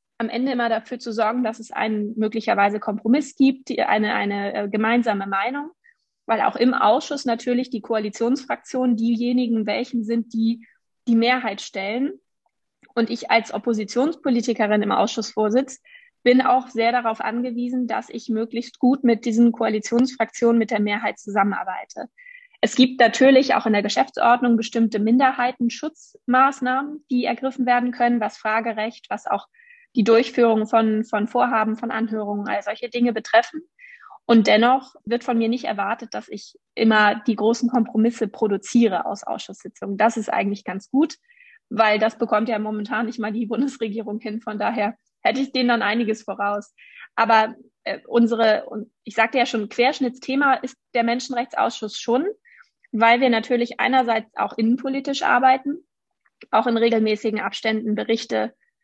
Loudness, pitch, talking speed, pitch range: -21 LUFS, 235 Hz, 150 wpm, 220-255 Hz